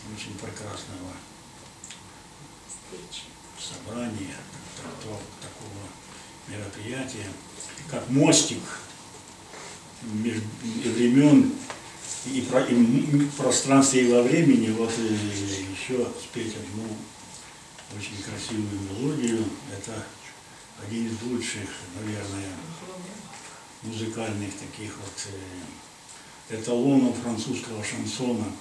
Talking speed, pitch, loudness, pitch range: 65 wpm, 110 Hz, -26 LUFS, 105-125 Hz